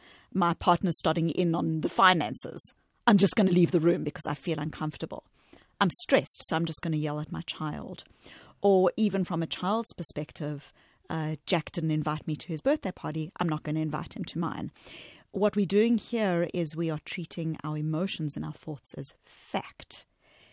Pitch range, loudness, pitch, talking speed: 155-185 Hz, -28 LUFS, 165 Hz, 195 wpm